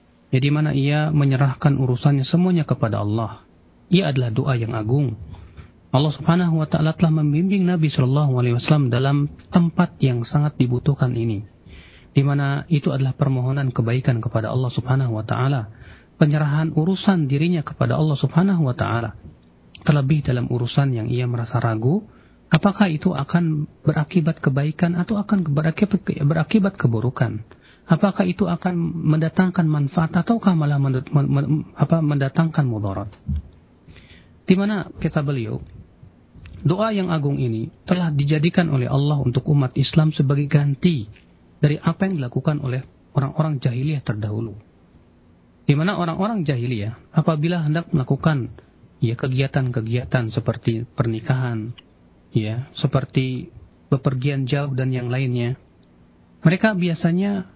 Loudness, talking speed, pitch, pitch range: -21 LUFS, 125 wpm, 140 Hz, 125-160 Hz